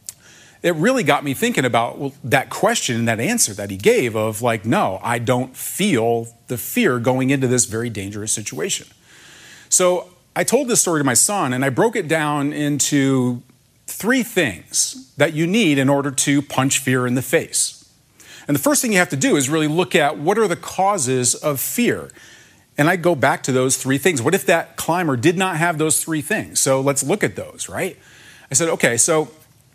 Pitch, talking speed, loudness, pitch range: 140 Hz, 205 wpm, -18 LUFS, 125-165 Hz